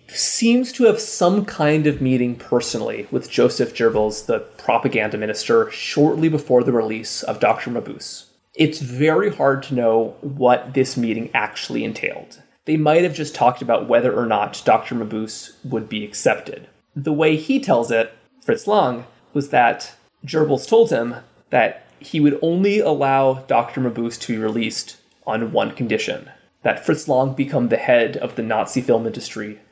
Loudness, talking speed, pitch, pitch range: -19 LUFS, 165 wpm, 130 Hz, 115-155 Hz